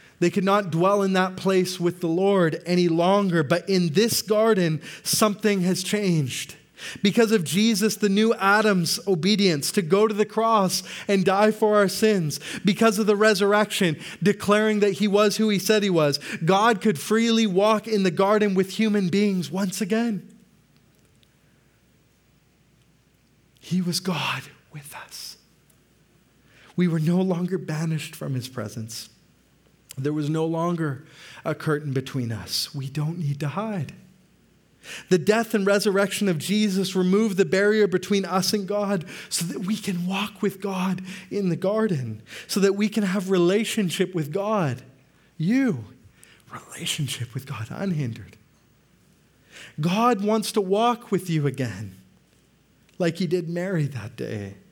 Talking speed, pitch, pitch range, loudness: 150 wpm, 190 Hz, 160-210 Hz, -23 LUFS